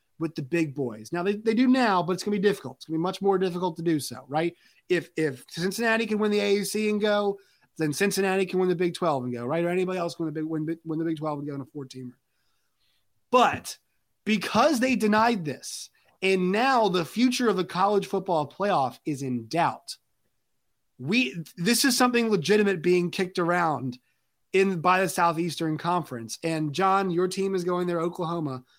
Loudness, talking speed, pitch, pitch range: -26 LUFS, 210 wpm, 180 Hz, 160-200 Hz